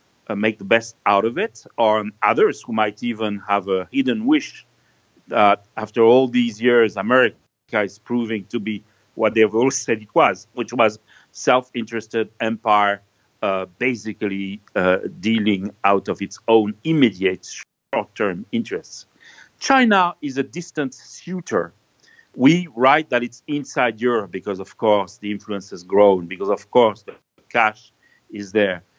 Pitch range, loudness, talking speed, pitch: 100-125 Hz, -20 LUFS, 145 wpm, 110 Hz